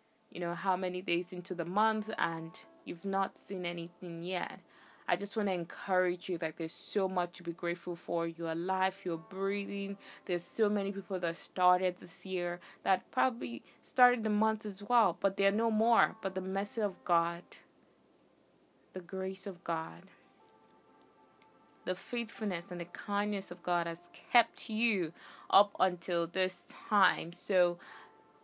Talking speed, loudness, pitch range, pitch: 160 wpm, -33 LUFS, 175-200 Hz, 185 Hz